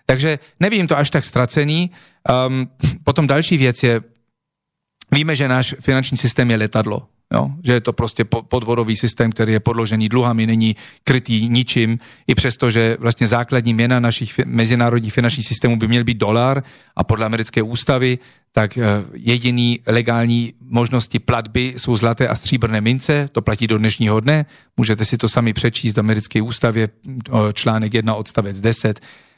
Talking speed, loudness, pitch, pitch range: 155 wpm, -17 LUFS, 120 Hz, 115-130 Hz